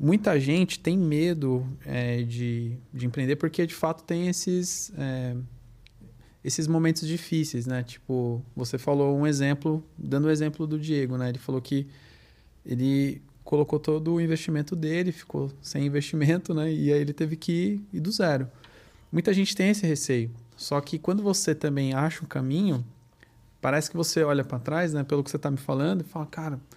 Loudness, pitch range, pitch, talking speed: -27 LUFS, 130-165 Hz, 150 Hz, 180 wpm